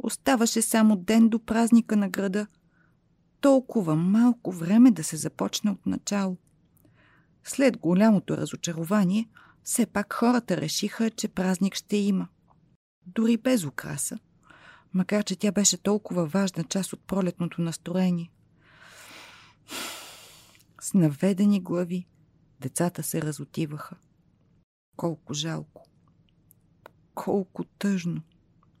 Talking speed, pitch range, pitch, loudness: 100 wpm, 165-215 Hz, 190 Hz, -26 LUFS